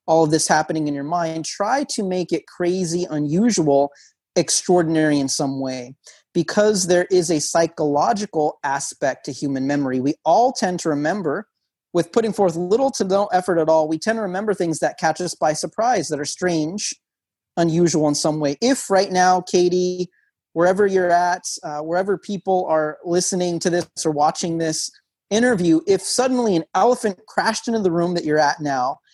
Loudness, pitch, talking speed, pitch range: -20 LUFS, 175 Hz, 180 wpm, 155-190 Hz